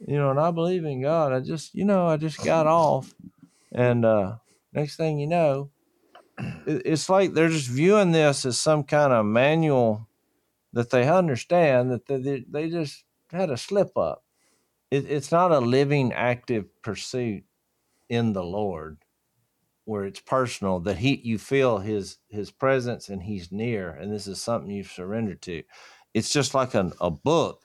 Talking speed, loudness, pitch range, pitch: 175 wpm, -24 LUFS, 110-150 Hz, 130 Hz